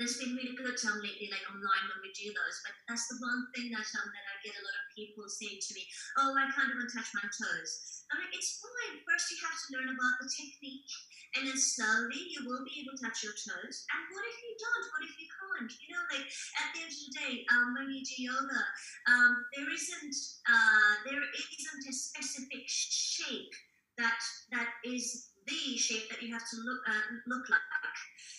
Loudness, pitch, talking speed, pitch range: -34 LUFS, 260 Hz, 220 wpm, 230-300 Hz